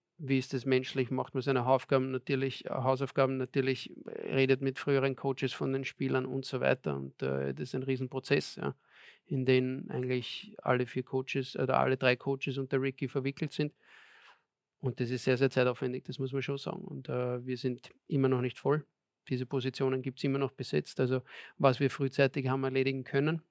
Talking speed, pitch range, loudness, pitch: 190 wpm, 130-135 Hz, -32 LUFS, 135 Hz